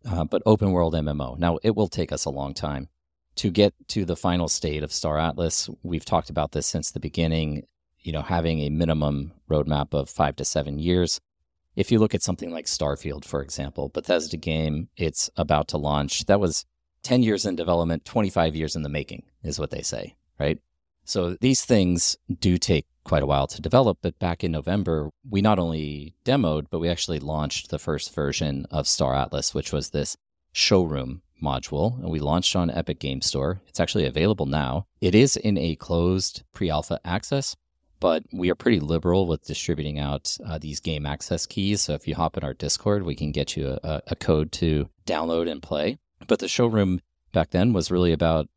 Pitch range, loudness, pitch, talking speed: 75-90 Hz, -25 LUFS, 80 Hz, 200 wpm